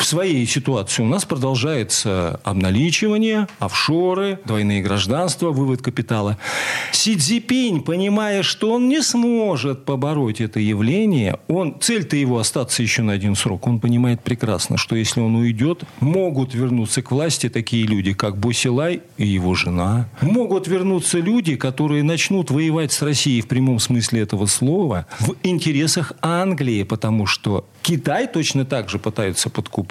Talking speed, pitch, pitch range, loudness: 145 wpm, 130 Hz, 110-170 Hz, -19 LUFS